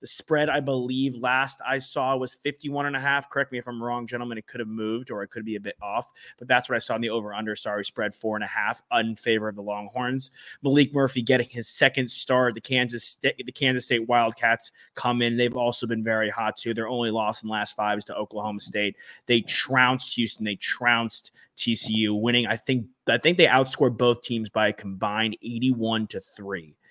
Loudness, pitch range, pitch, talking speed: -25 LUFS, 110-130 Hz, 120 Hz, 225 wpm